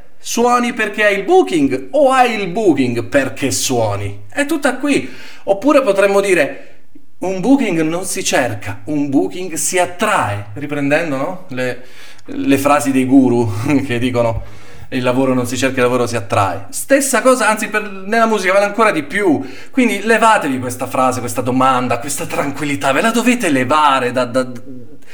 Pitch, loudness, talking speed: 145 Hz, -15 LUFS, 160 wpm